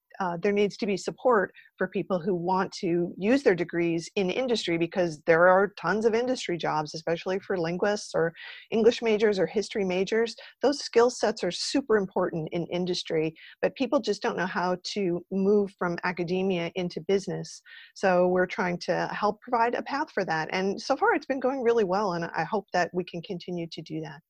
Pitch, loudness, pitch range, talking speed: 190 Hz, -27 LUFS, 175-220 Hz, 200 wpm